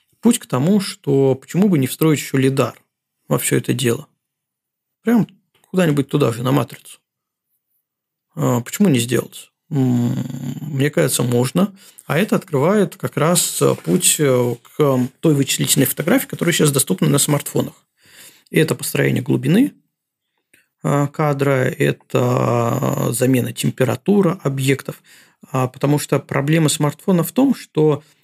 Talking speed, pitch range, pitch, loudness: 120 wpm, 130-170 Hz, 145 Hz, -18 LUFS